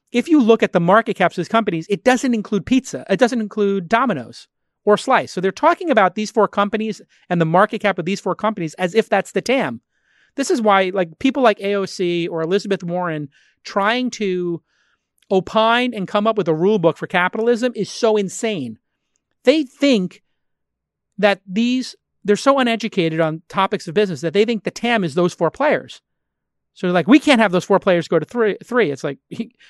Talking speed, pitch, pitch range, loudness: 200 wpm, 205 Hz, 180-230 Hz, -18 LUFS